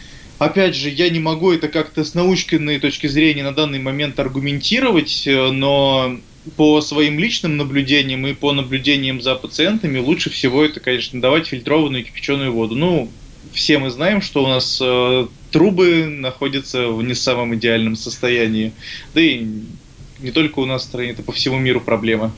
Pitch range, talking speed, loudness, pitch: 125-155 Hz, 165 wpm, -17 LUFS, 140 Hz